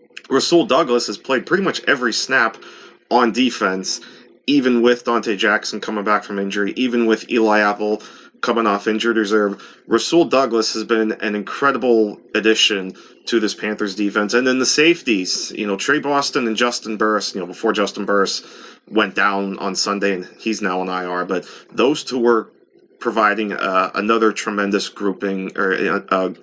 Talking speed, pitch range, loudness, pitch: 170 wpm, 100-120 Hz, -18 LUFS, 110 Hz